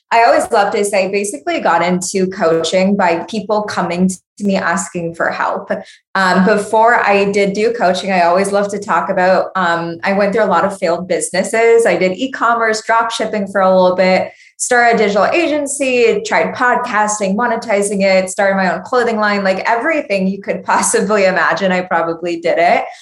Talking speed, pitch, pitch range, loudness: 185 wpm, 200 Hz, 185-225 Hz, -14 LUFS